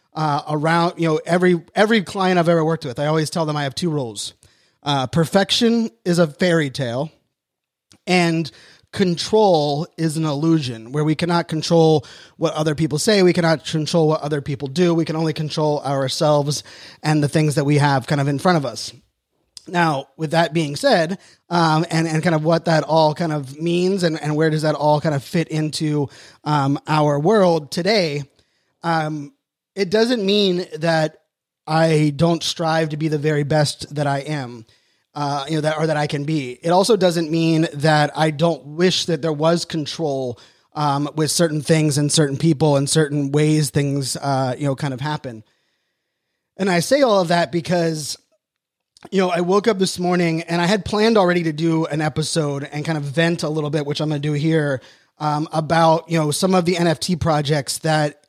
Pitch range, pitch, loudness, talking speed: 150-170 Hz, 155 Hz, -19 LUFS, 200 wpm